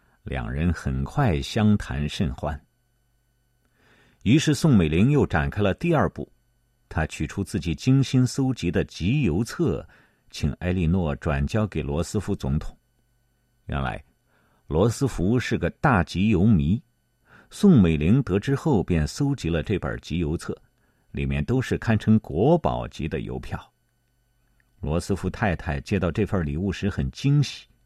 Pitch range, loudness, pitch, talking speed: 80-125 Hz, -24 LUFS, 100 Hz, 210 characters per minute